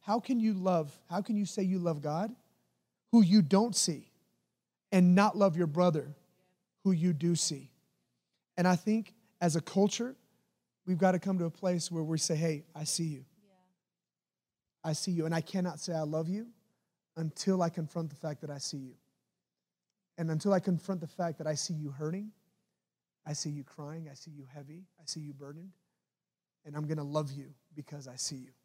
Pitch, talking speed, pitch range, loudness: 170 Hz, 200 wpm, 150-190 Hz, -32 LUFS